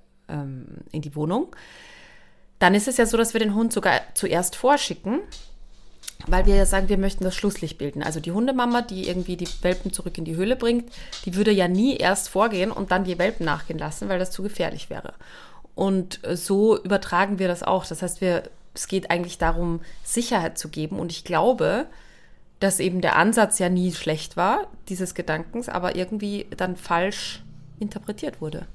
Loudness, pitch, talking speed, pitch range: -24 LUFS, 185 Hz, 185 wpm, 170-205 Hz